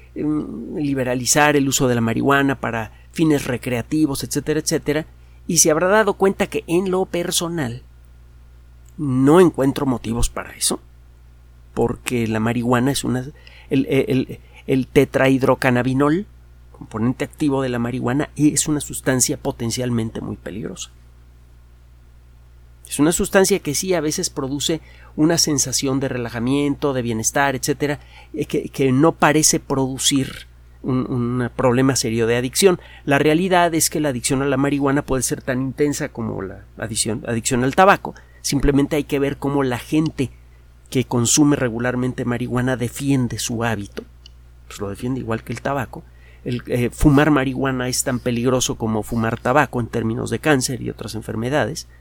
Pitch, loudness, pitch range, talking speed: 130 Hz, -19 LUFS, 115-145 Hz, 150 wpm